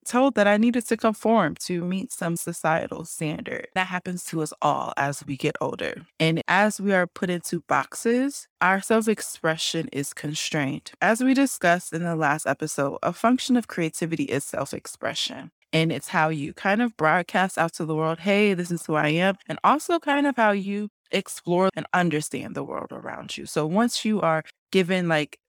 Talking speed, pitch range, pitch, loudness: 195 wpm, 160-210 Hz, 180 Hz, -24 LUFS